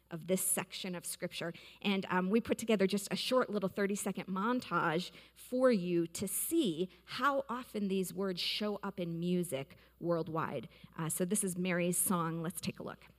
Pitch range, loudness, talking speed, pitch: 175-205 Hz, -35 LUFS, 180 wpm, 185 Hz